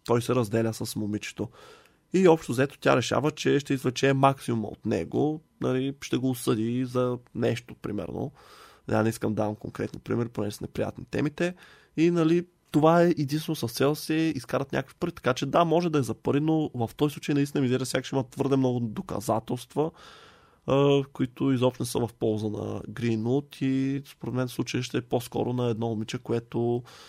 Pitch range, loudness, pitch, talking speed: 115-145 Hz, -27 LUFS, 130 Hz, 190 wpm